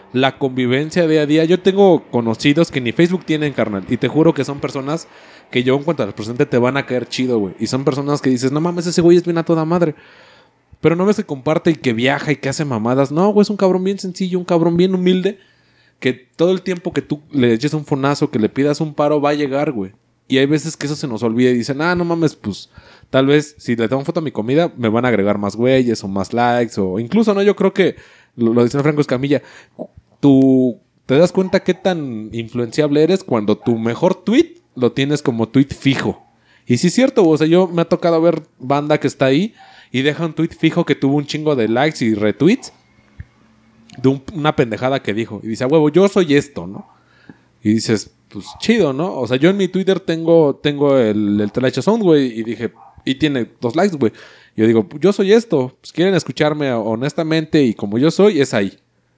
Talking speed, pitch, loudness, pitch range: 235 wpm, 145 Hz, -16 LUFS, 120-170 Hz